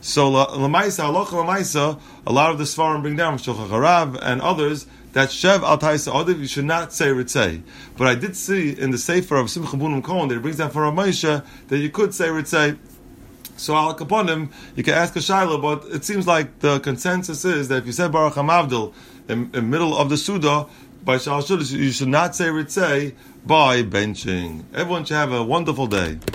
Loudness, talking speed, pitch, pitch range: -20 LUFS, 185 wpm, 150 Hz, 135-170 Hz